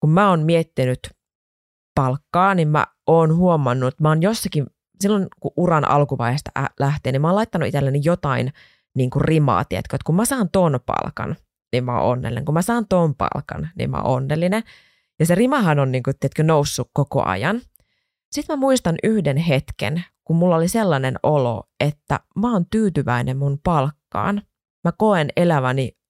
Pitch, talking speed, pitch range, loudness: 150 Hz, 175 wpm, 130-180 Hz, -20 LUFS